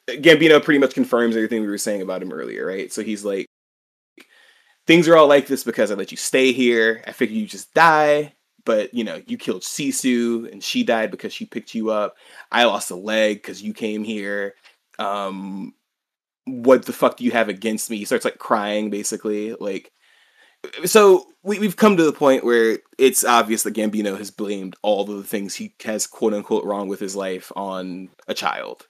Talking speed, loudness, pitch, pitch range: 200 wpm, -19 LUFS, 115 Hz, 105-145 Hz